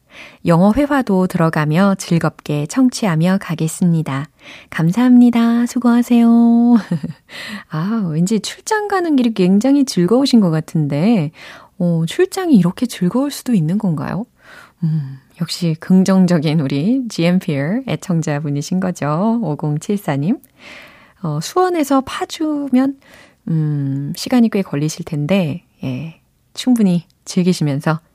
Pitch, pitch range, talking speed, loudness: 185 Hz, 160-240 Hz, 250 characters per minute, -16 LUFS